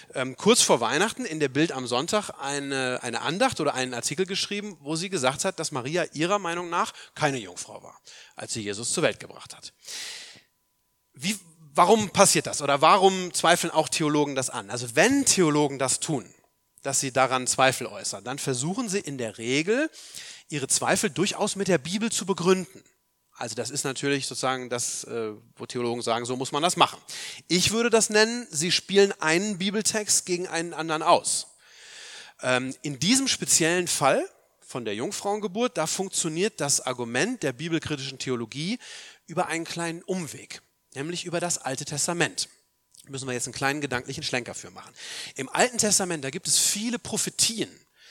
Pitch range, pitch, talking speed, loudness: 130-195 Hz, 160 Hz, 170 wpm, -25 LUFS